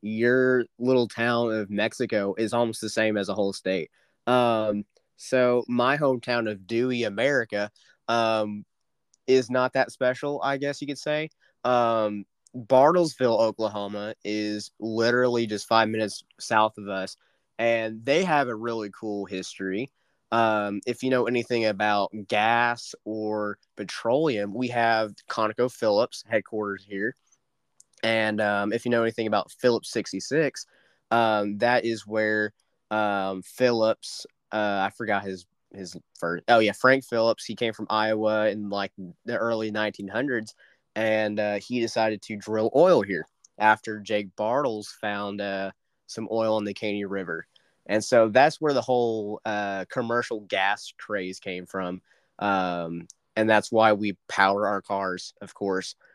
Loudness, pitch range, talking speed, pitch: -25 LUFS, 100-120 Hz, 145 wpm, 110 Hz